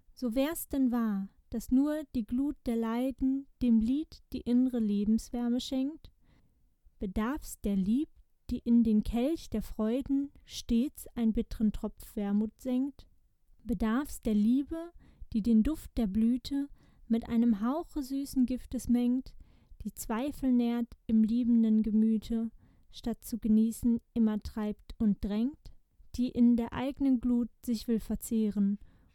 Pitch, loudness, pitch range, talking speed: 235 Hz, -31 LUFS, 220-260 Hz, 135 wpm